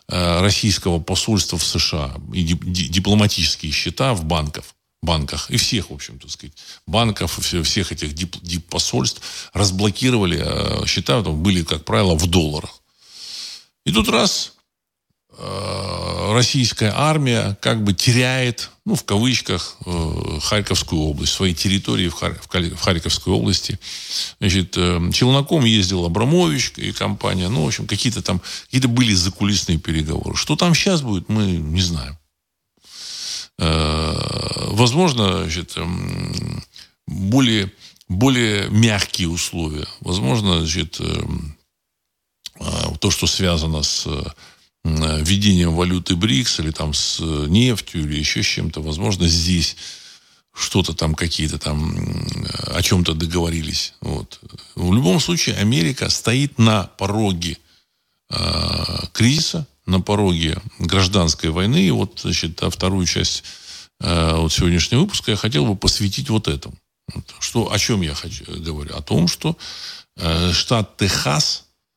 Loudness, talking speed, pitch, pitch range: -19 LUFS, 115 wpm, 90 Hz, 85-105 Hz